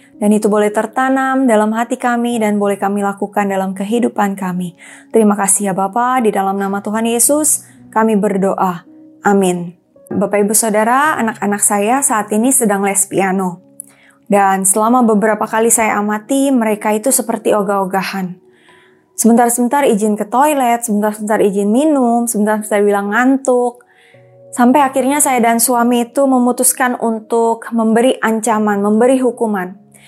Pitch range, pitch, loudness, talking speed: 200-245 Hz, 220 Hz, -13 LUFS, 135 wpm